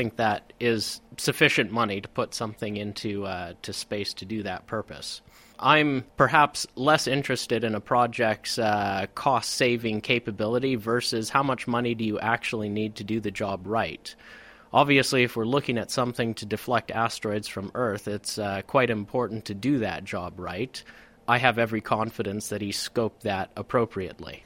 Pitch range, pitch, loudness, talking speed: 105-125 Hz, 115 Hz, -26 LUFS, 170 wpm